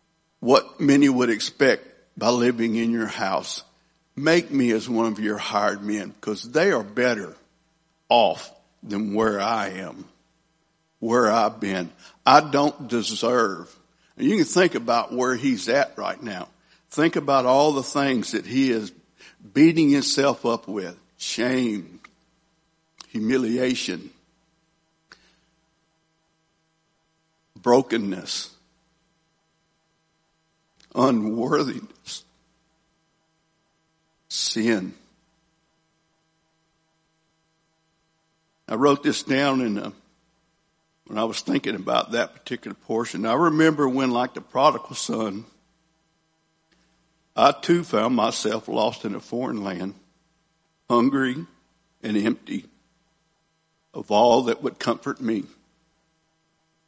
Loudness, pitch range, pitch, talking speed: -22 LUFS, 125-160 Hz, 160 Hz, 105 wpm